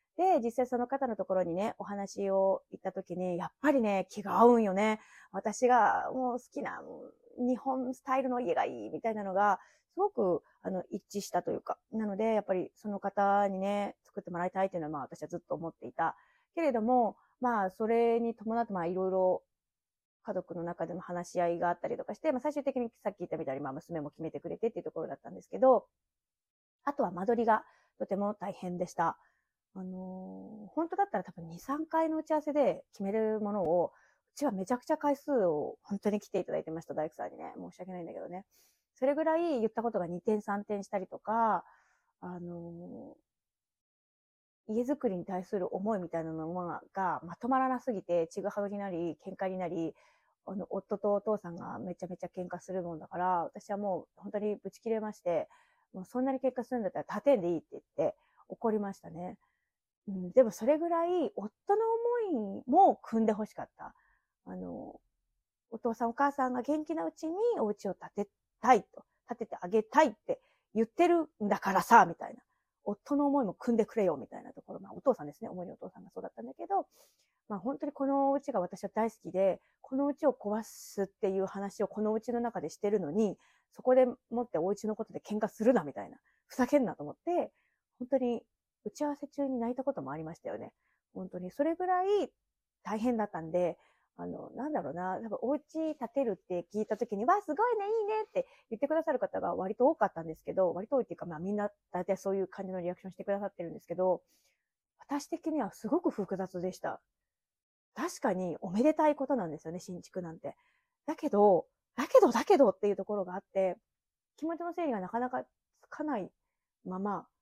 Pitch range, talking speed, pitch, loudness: 185-265 Hz, 395 characters per minute, 210 Hz, -33 LUFS